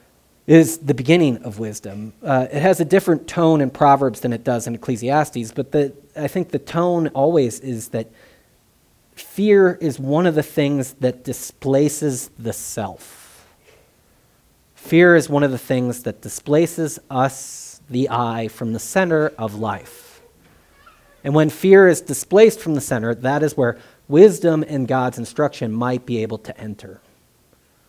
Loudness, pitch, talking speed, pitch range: -18 LUFS, 135 Hz, 155 wpm, 120-155 Hz